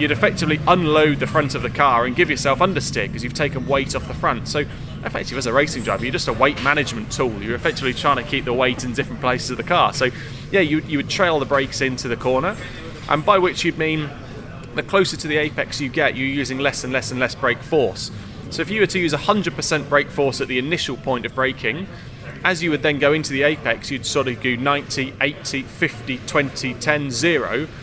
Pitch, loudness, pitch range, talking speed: 140 Hz, -20 LUFS, 130-155 Hz, 235 wpm